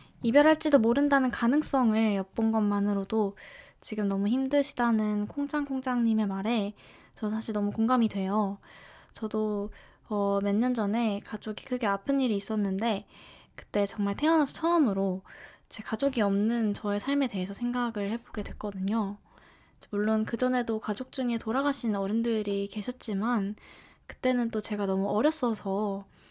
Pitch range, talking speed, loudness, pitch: 205-250 Hz, 310 characters per minute, -29 LUFS, 220 Hz